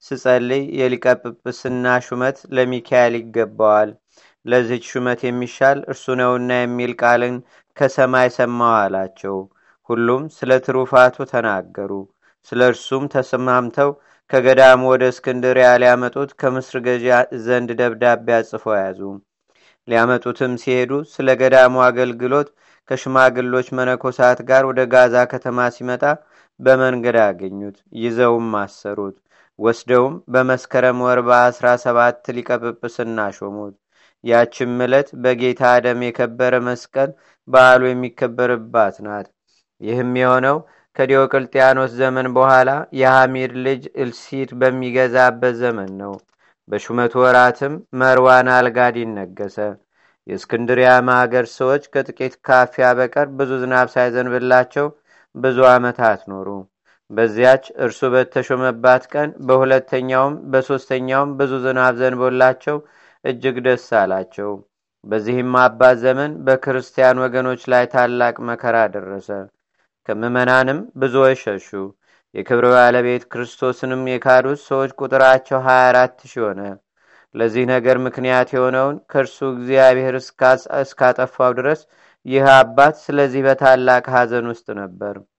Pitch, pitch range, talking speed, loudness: 125 Hz, 120-130 Hz, 100 wpm, -16 LUFS